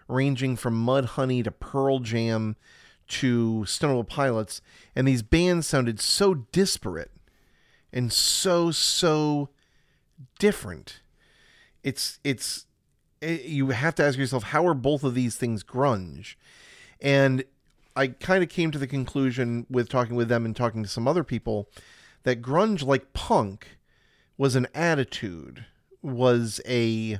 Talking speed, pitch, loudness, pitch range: 135 wpm, 130 Hz, -25 LUFS, 120-145 Hz